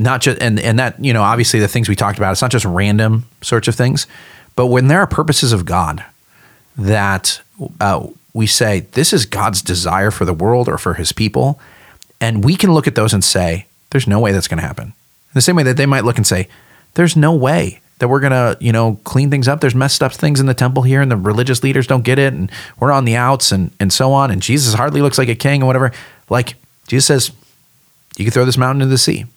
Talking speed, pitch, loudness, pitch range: 250 wpm, 125 Hz, -14 LUFS, 105-135 Hz